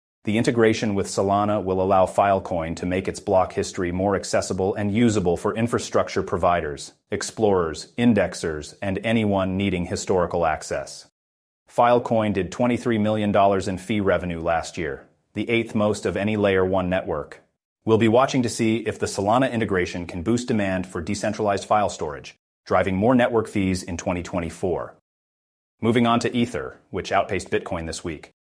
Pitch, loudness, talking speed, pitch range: 100 Hz, -23 LUFS, 155 wpm, 95-115 Hz